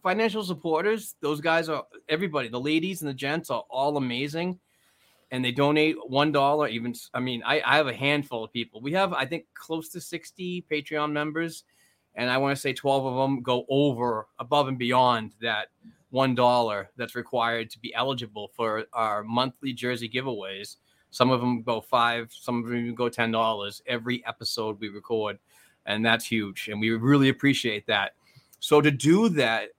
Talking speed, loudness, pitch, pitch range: 185 wpm, -26 LUFS, 130 Hz, 115-150 Hz